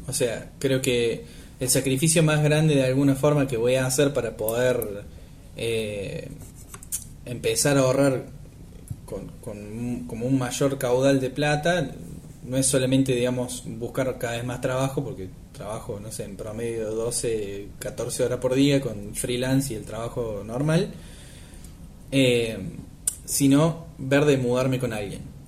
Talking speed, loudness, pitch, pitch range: 150 wpm, -24 LUFS, 130 Hz, 115-140 Hz